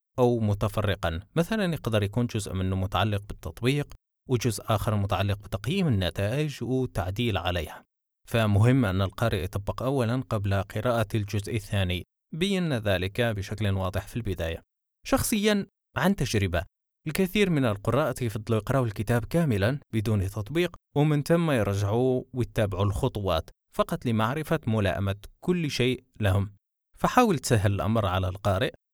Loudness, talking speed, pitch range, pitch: -27 LUFS, 120 wpm, 100-130 Hz, 110 Hz